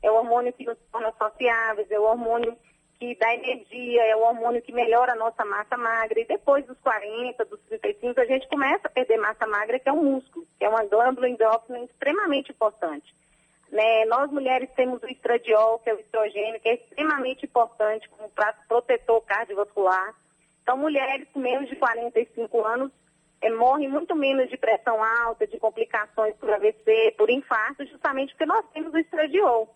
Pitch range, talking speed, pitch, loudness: 220-270 Hz, 180 wpm, 235 Hz, -24 LUFS